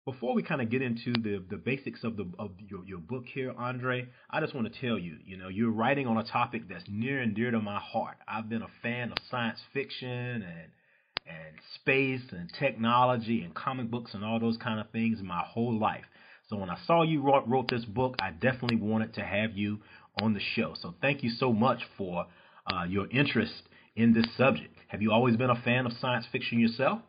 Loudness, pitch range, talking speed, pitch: -31 LUFS, 110-130 Hz, 225 wpm, 115 Hz